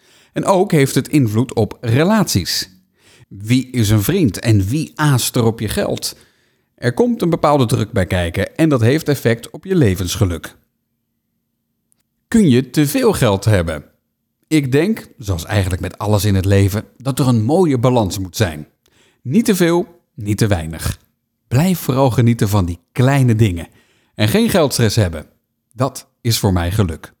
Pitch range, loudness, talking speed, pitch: 100-145 Hz, -16 LUFS, 170 wpm, 115 Hz